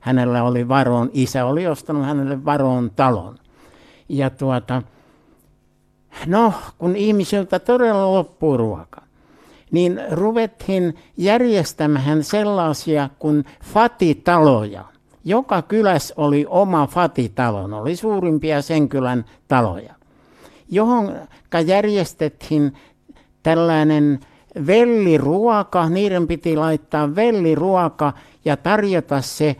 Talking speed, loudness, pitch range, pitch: 90 wpm, -18 LUFS, 140-190 Hz, 155 Hz